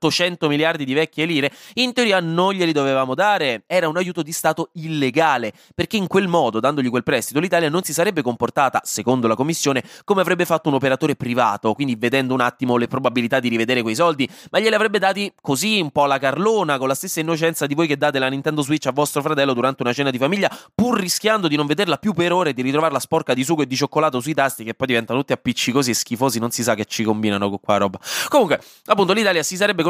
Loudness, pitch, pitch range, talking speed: -19 LUFS, 145 Hz, 130-170 Hz, 235 wpm